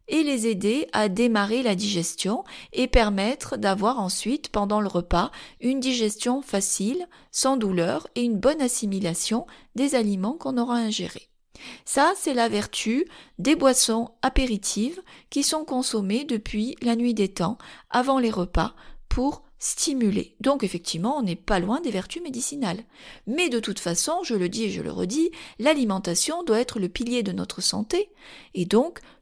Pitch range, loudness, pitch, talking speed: 205-270 Hz, -24 LUFS, 235 Hz, 160 wpm